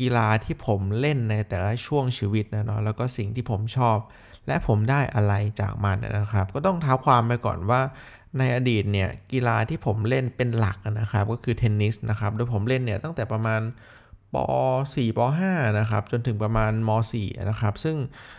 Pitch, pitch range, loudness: 110 Hz, 105-125 Hz, -25 LUFS